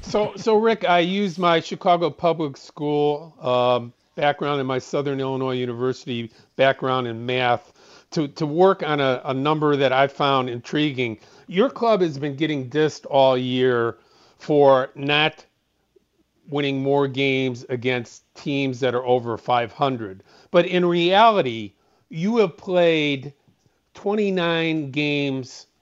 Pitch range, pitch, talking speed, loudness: 130-165 Hz, 140 Hz, 130 wpm, -21 LUFS